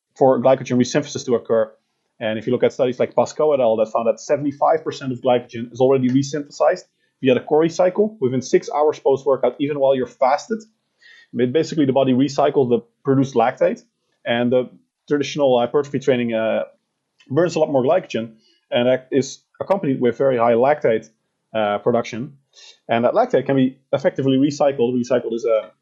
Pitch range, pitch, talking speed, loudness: 120-150 Hz, 135 Hz, 175 wpm, -19 LUFS